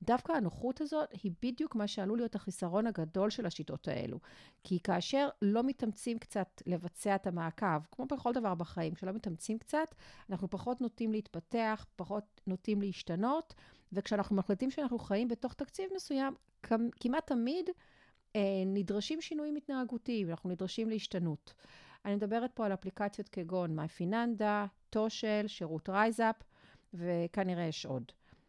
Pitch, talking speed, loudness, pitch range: 210 Hz, 135 wpm, -37 LUFS, 185-240 Hz